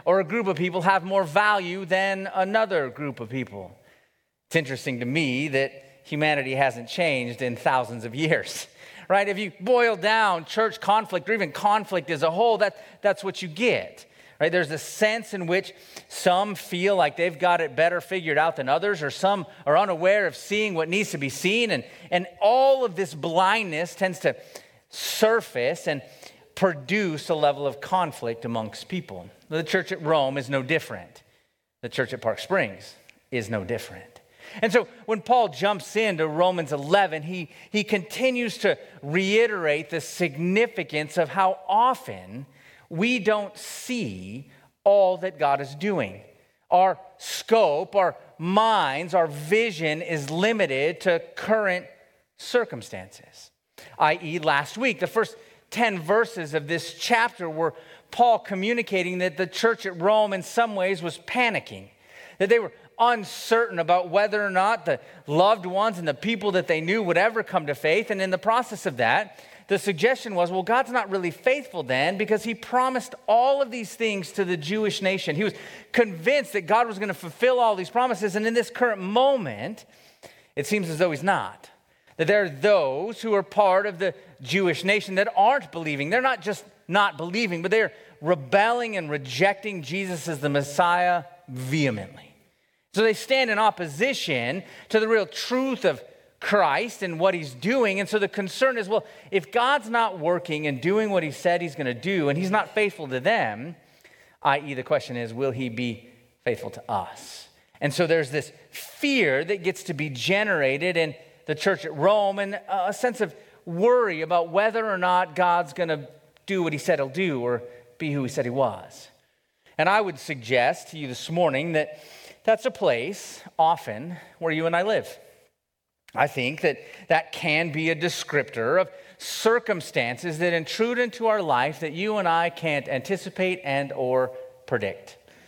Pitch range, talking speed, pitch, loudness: 160-215 Hz, 175 wpm, 185 Hz, -24 LUFS